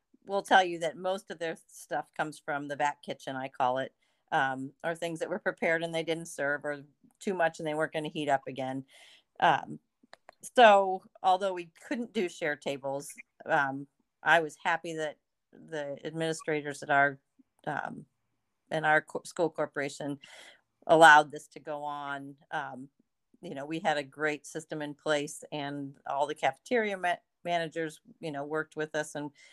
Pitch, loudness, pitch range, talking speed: 155 Hz, -30 LUFS, 145-170 Hz, 175 wpm